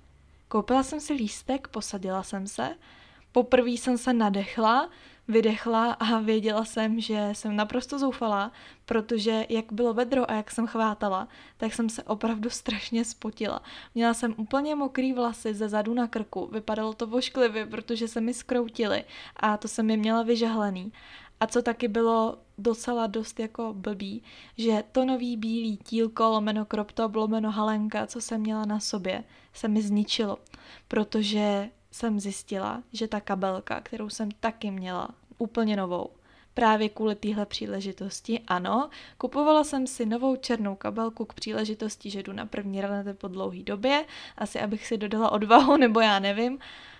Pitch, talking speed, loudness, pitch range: 225 Hz, 155 wpm, -28 LUFS, 215-235 Hz